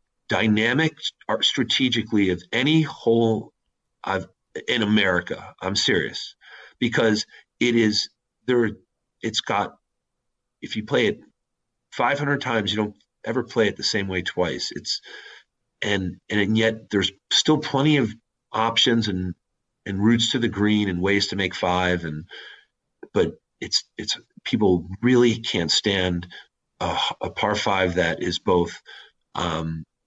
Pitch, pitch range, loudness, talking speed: 110 Hz, 95-120 Hz, -23 LUFS, 135 wpm